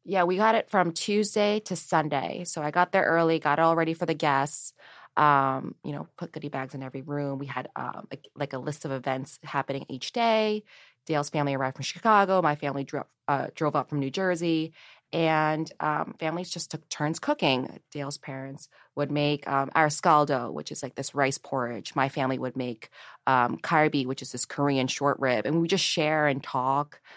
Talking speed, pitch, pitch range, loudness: 205 wpm, 150 Hz, 135-165 Hz, -27 LUFS